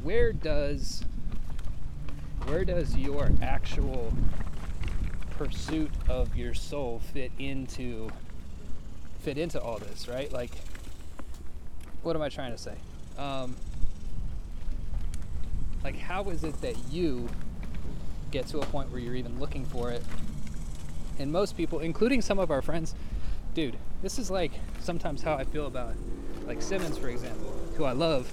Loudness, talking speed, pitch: -34 LUFS, 140 wpm, 90 Hz